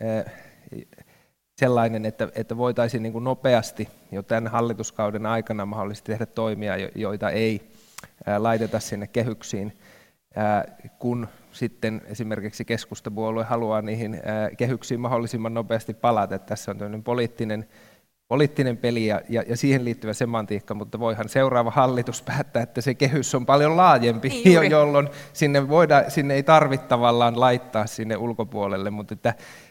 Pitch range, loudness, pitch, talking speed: 110-125 Hz, -23 LUFS, 115 Hz, 125 wpm